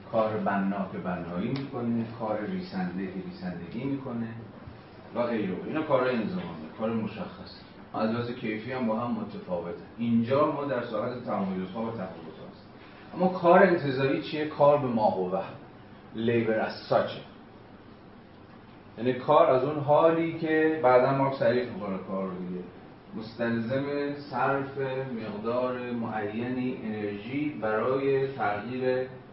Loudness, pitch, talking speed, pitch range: -28 LUFS, 120 Hz, 125 wpm, 105-135 Hz